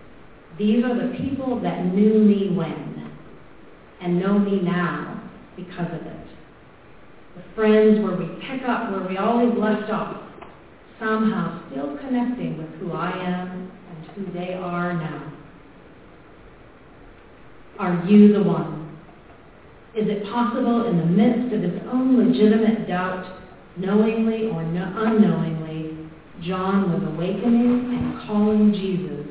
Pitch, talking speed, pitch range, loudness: 195 Hz, 125 wpm, 175-220 Hz, -21 LUFS